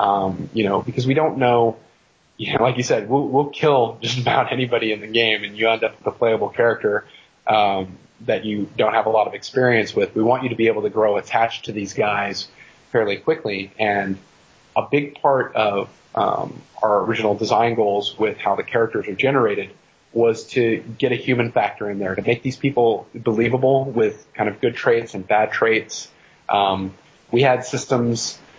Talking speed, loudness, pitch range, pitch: 195 wpm, -20 LUFS, 105-125 Hz, 115 Hz